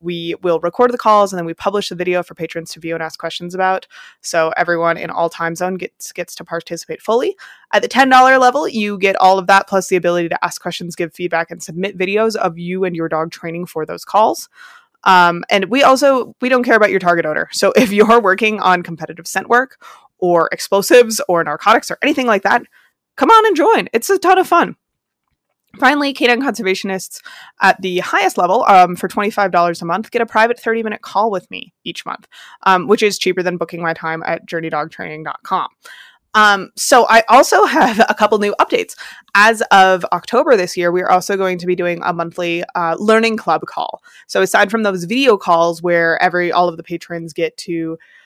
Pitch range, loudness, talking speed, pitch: 170-225 Hz, -14 LUFS, 210 wpm, 185 Hz